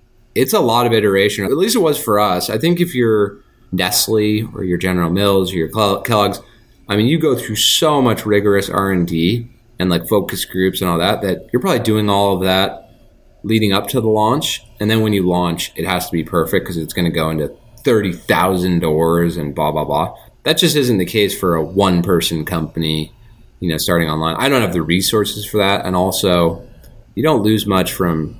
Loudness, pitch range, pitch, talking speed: -16 LUFS, 85-110 Hz, 95 Hz, 215 wpm